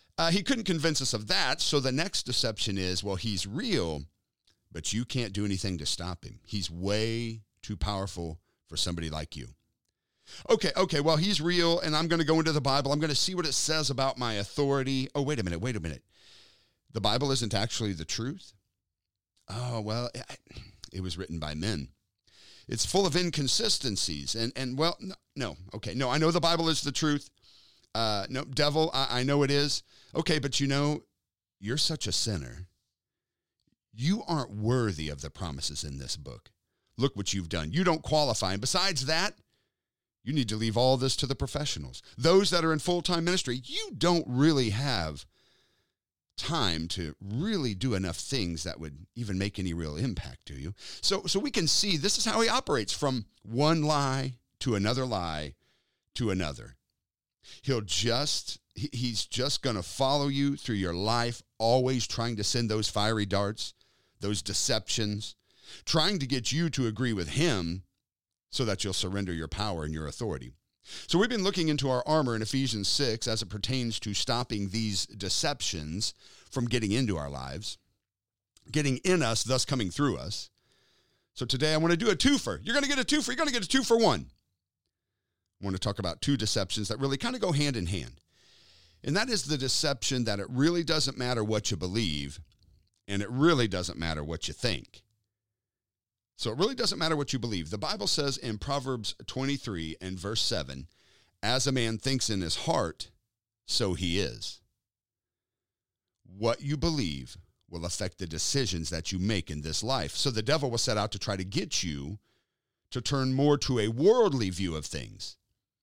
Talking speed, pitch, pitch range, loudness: 185 wpm, 115 Hz, 95-140 Hz, -29 LUFS